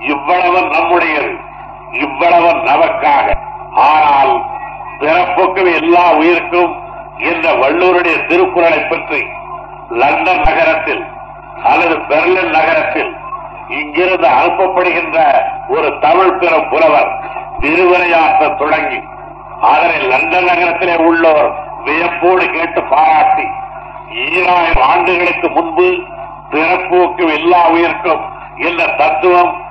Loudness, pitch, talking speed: -11 LUFS, 180 Hz, 80 wpm